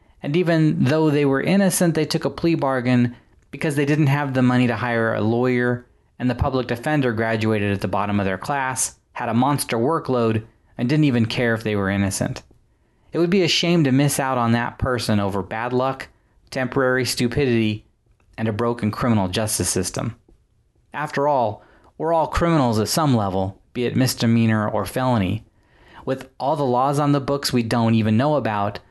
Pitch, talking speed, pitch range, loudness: 125 Hz, 190 wpm, 110-140 Hz, -21 LUFS